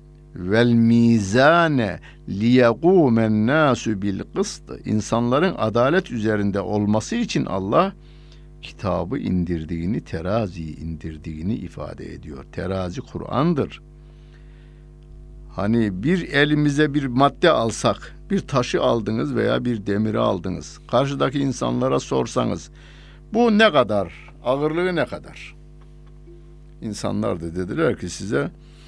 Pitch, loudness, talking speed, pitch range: 120 Hz, -21 LUFS, 90 wpm, 100-155 Hz